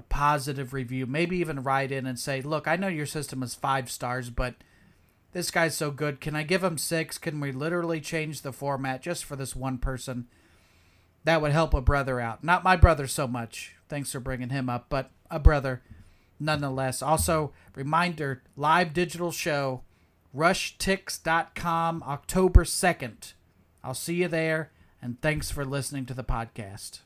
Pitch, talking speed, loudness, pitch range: 140 Hz, 170 wpm, -28 LUFS, 130-160 Hz